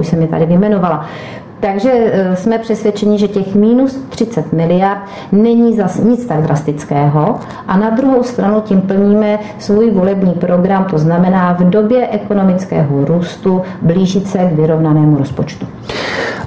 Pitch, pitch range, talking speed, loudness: 195 Hz, 170-215 Hz, 140 wpm, -12 LUFS